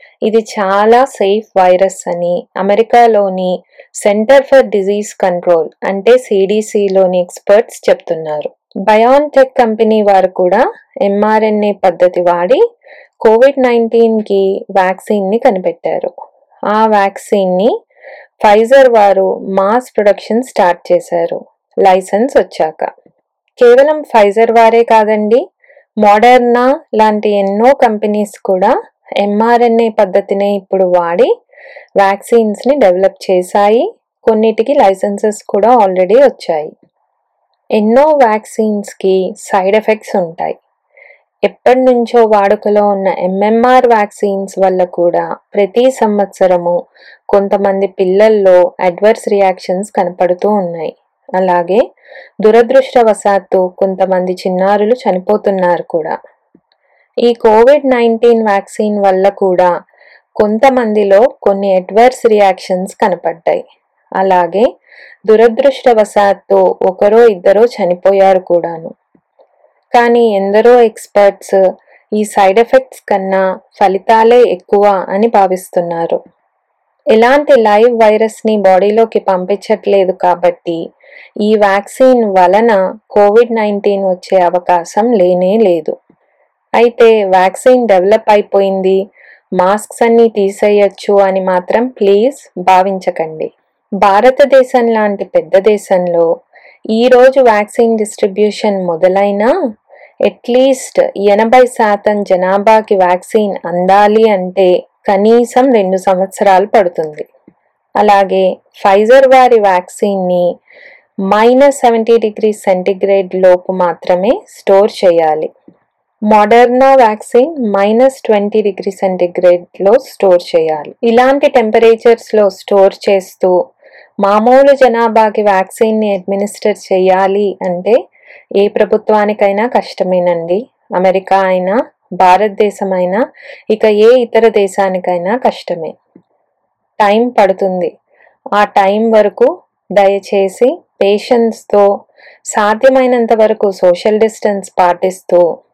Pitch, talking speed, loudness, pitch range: 205 Hz, 85 wpm, -10 LUFS, 190-230 Hz